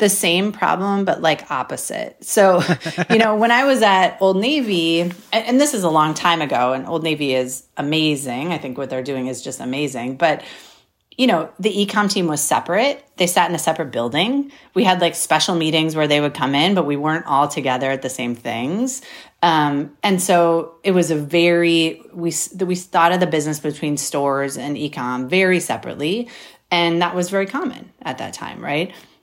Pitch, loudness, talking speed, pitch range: 170 Hz, -18 LUFS, 205 wpm, 145-190 Hz